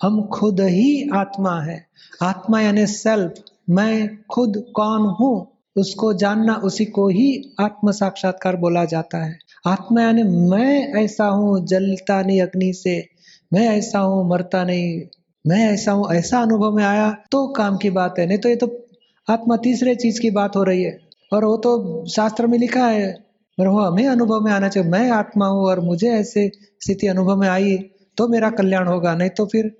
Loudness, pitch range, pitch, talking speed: -18 LUFS, 185-220 Hz, 205 Hz, 185 wpm